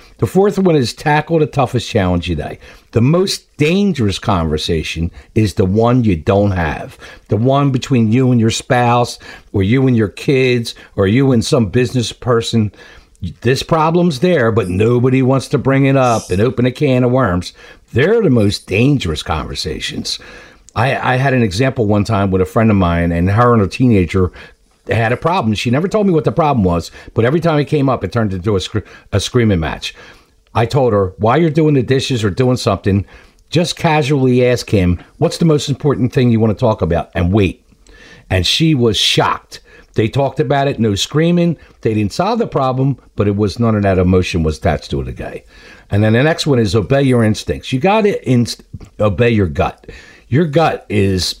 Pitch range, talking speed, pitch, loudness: 100-135 Hz, 205 wpm, 115 Hz, -14 LUFS